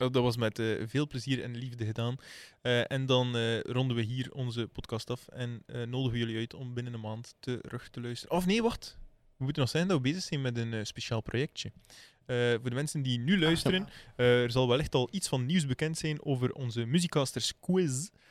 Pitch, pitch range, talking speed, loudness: 125 Hz, 120-140 Hz, 225 wpm, -32 LUFS